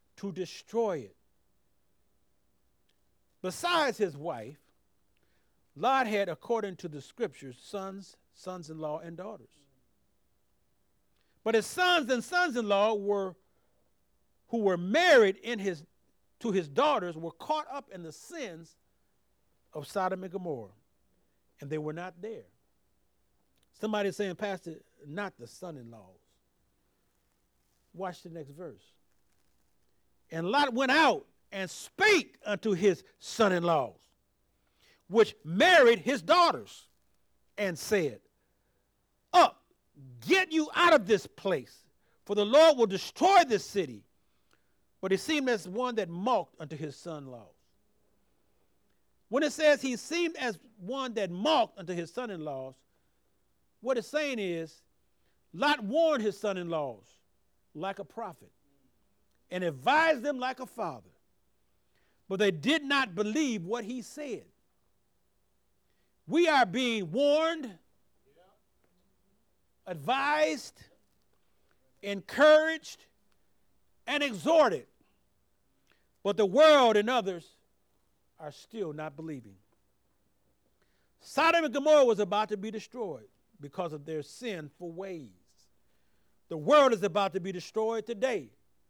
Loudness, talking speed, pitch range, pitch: -28 LUFS, 120 wpm, 155-255 Hz, 195 Hz